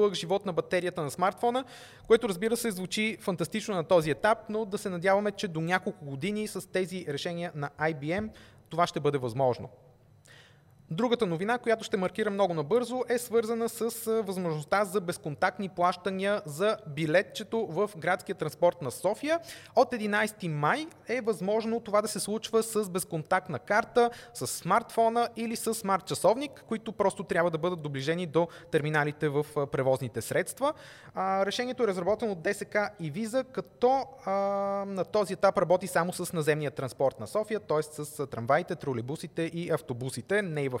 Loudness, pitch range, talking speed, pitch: -30 LUFS, 160-215 Hz, 155 wpm, 190 Hz